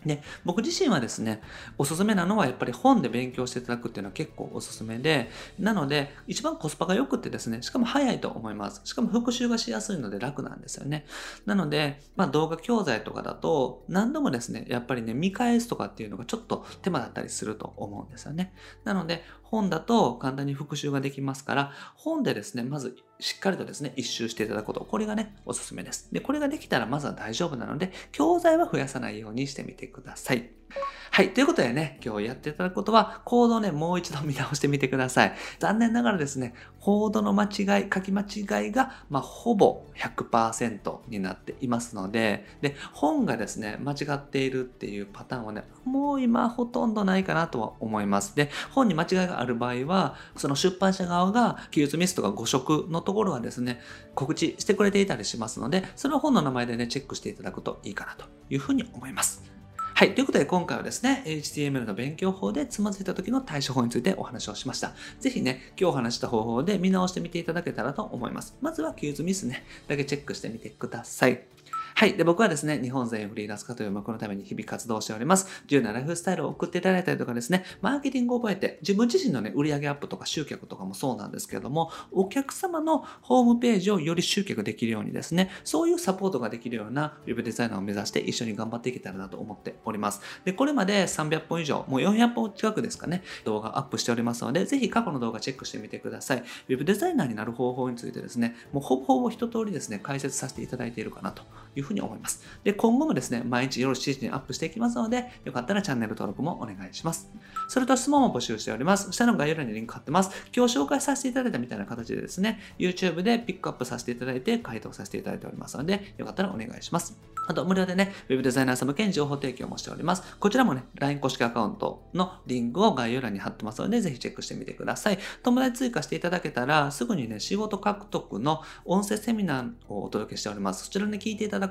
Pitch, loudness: 160 Hz, -28 LUFS